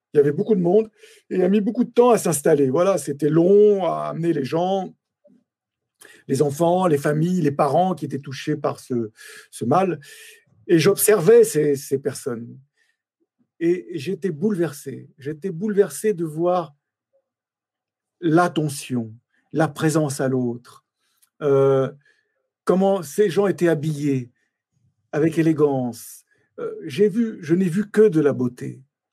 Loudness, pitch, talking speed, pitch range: -20 LUFS, 165 Hz, 145 wpm, 145-205 Hz